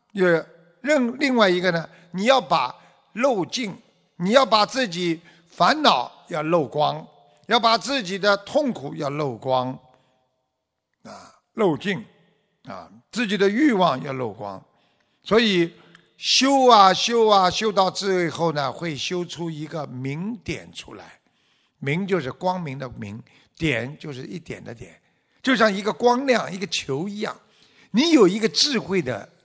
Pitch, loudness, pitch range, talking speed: 180 Hz, -21 LUFS, 145-220 Hz, 200 characters per minute